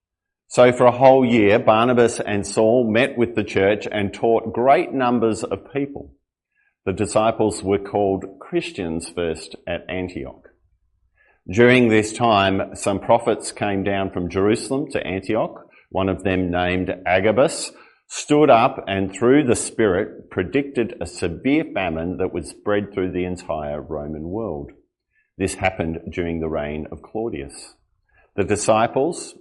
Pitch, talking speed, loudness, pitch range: 100 Hz, 140 wpm, -20 LUFS, 90-115 Hz